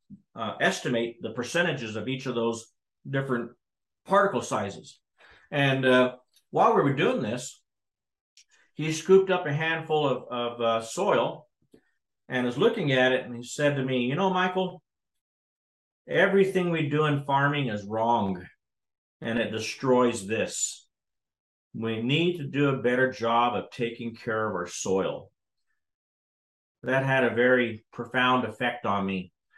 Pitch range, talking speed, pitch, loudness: 115-145 Hz, 145 wpm, 125 Hz, -26 LUFS